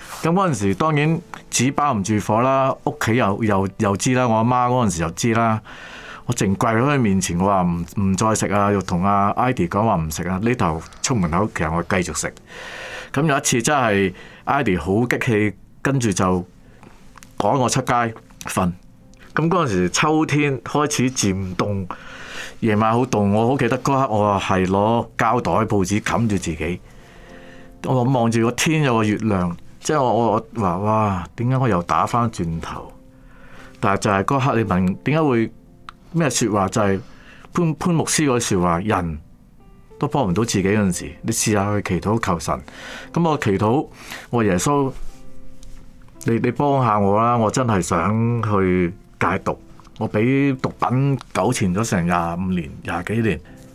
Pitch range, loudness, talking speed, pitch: 95-125 Hz, -20 LUFS, 240 characters per minute, 105 Hz